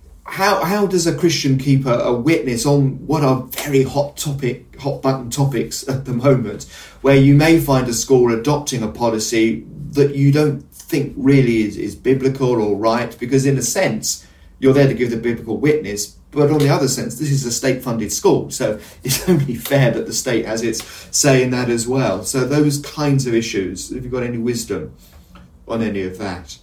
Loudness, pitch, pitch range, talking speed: -17 LUFS, 130 Hz, 115-140 Hz, 205 wpm